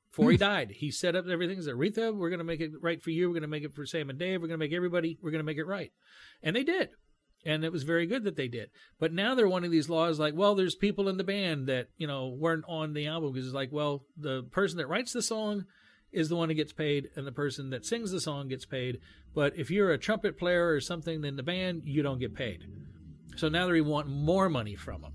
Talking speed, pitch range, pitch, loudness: 280 wpm, 140-180 Hz, 160 Hz, -31 LUFS